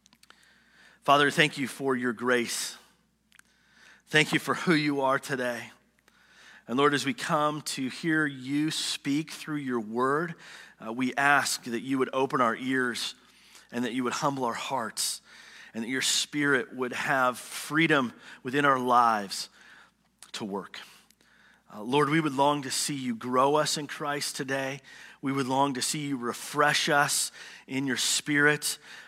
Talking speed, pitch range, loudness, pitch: 160 wpm, 130-150 Hz, -27 LUFS, 140 Hz